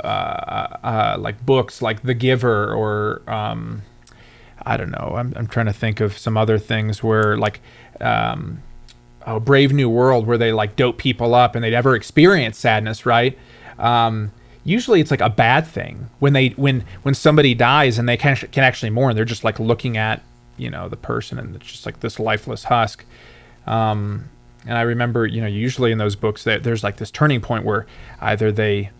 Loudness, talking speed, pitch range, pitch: -18 LUFS, 200 wpm, 110-125 Hz, 115 Hz